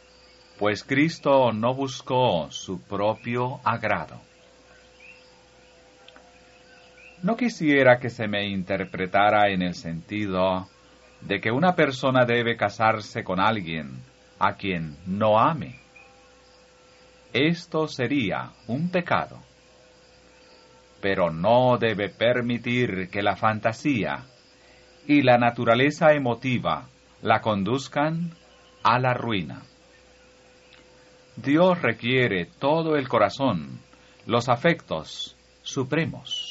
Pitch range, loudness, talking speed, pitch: 90-130 Hz, -24 LUFS, 90 wpm, 110 Hz